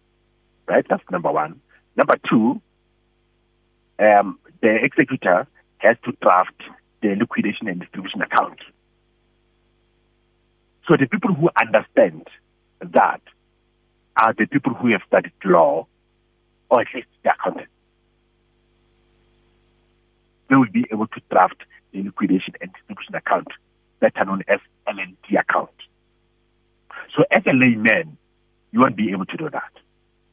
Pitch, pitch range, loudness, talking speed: 115 Hz, 90-120 Hz, -19 LUFS, 125 wpm